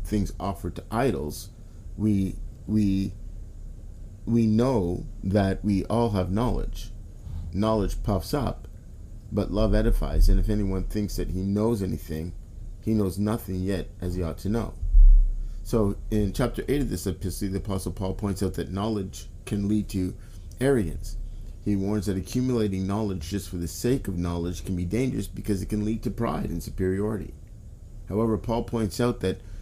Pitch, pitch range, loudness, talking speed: 100 Hz, 90-110 Hz, -27 LUFS, 165 wpm